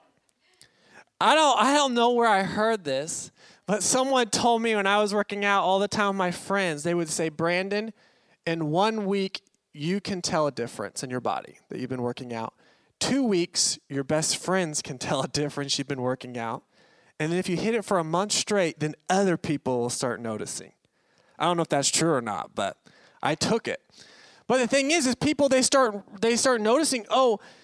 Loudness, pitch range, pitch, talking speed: -25 LUFS, 150-225 Hz, 190 Hz, 210 wpm